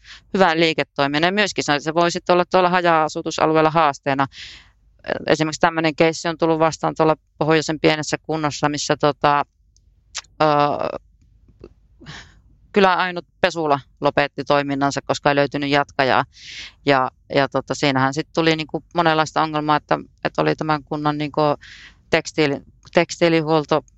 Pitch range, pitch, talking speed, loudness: 140-160 Hz, 150 Hz, 125 wpm, -19 LUFS